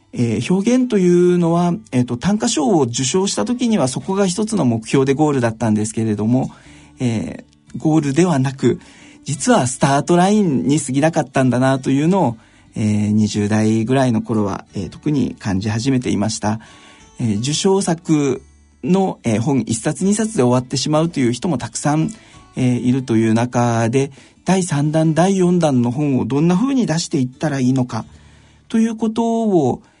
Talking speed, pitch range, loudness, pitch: 340 characters per minute, 115-175 Hz, -17 LUFS, 135 Hz